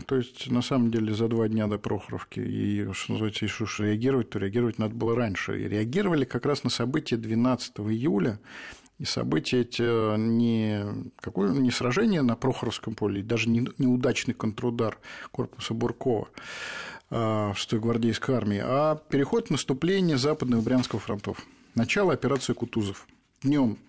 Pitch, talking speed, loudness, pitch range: 115 Hz, 150 wpm, -27 LUFS, 110-125 Hz